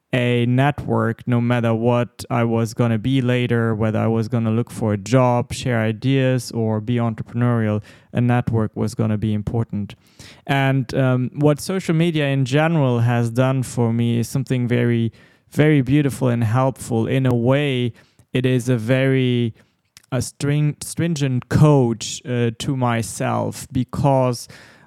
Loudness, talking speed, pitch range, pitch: -20 LUFS, 150 wpm, 115-130 Hz, 120 Hz